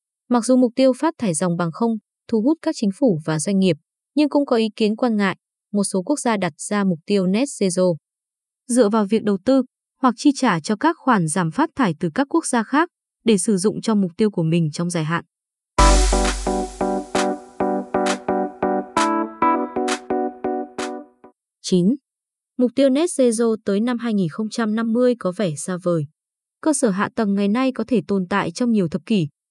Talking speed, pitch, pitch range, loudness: 185 wpm, 215 Hz, 180-250 Hz, -20 LUFS